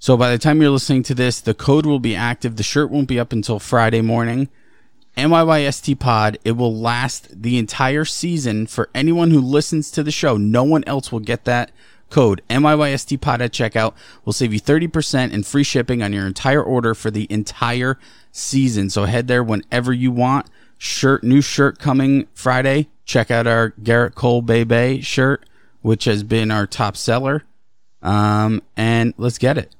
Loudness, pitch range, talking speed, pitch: -17 LUFS, 115-140 Hz, 185 wpm, 125 Hz